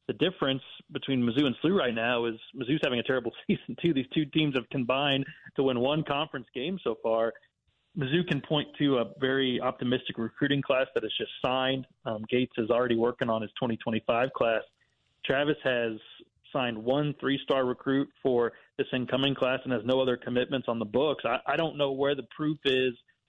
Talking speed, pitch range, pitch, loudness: 195 wpm, 120-145 Hz, 130 Hz, -29 LUFS